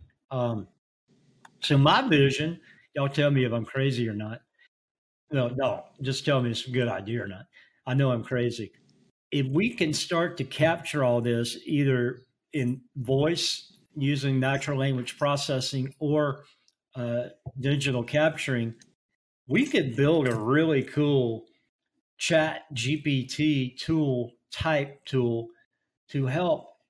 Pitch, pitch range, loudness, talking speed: 135 Hz, 125-145 Hz, -27 LUFS, 130 wpm